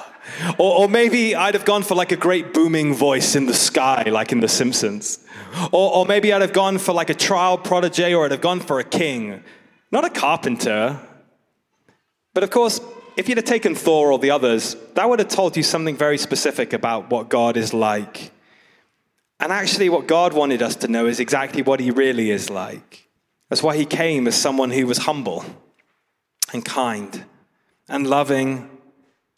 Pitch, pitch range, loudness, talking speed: 160 Hz, 135-185 Hz, -19 LUFS, 190 wpm